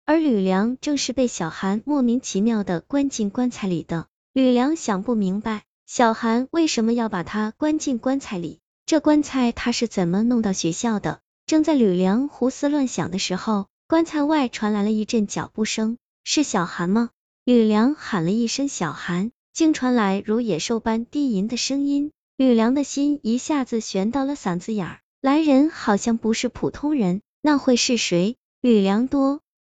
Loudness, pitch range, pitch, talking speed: -22 LUFS, 210-275 Hz, 235 Hz, 255 characters per minute